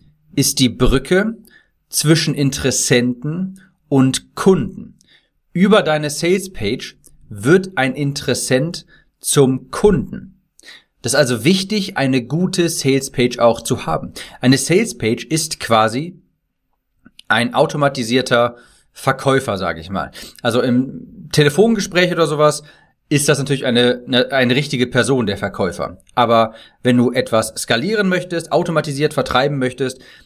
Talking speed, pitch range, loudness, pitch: 125 wpm, 125-175 Hz, -17 LUFS, 140 Hz